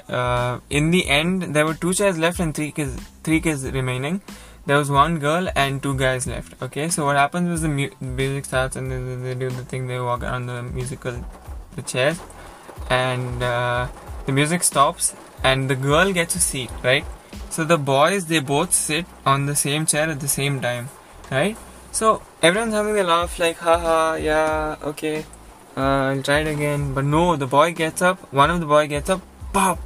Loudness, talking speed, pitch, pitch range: -21 LUFS, 200 wpm, 145 Hz, 135-165 Hz